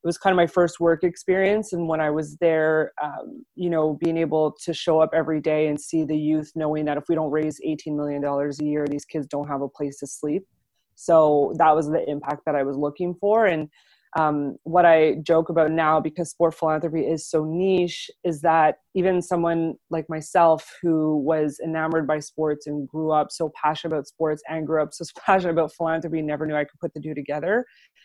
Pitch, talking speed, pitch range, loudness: 160 Hz, 215 wpm, 150-170 Hz, -23 LUFS